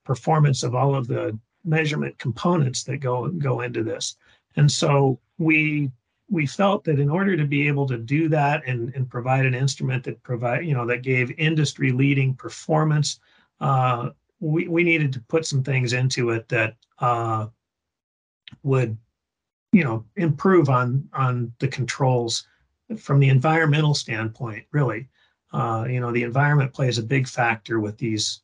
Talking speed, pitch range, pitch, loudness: 160 wpm, 120-150 Hz, 135 Hz, -22 LUFS